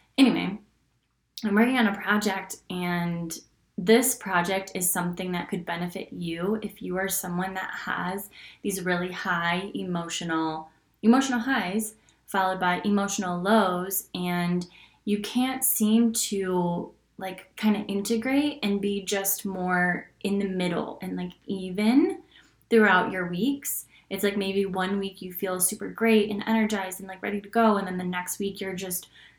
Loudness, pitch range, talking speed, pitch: -26 LUFS, 180-215 Hz, 155 wpm, 195 Hz